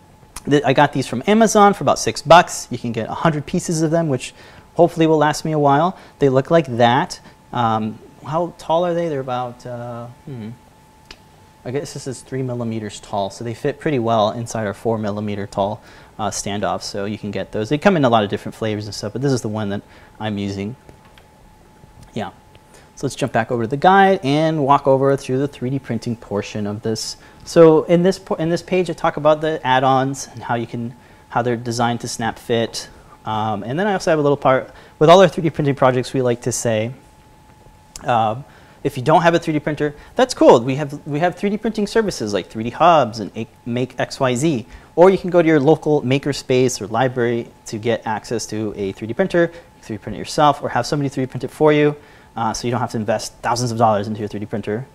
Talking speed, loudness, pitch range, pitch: 225 wpm, -18 LUFS, 115-155 Hz, 130 Hz